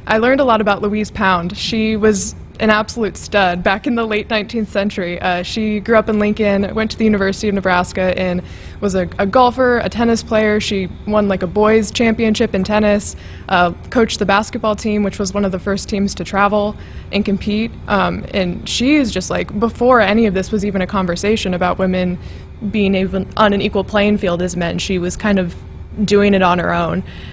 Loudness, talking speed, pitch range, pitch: -16 LUFS, 210 wpm, 190-220 Hz, 205 Hz